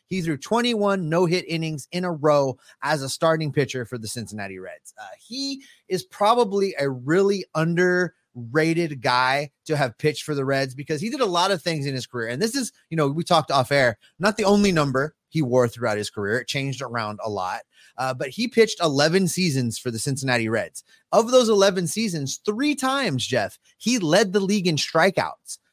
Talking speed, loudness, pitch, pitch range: 205 wpm, -23 LUFS, 160 Hz, 135-195 Hz